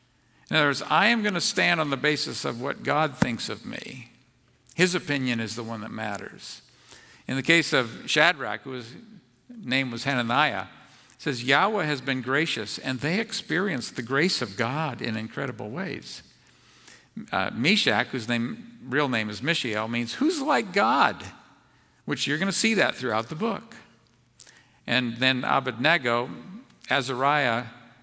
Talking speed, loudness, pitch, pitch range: 155 wpm, -25 LUFS, 135 Hz, 120-165 Hz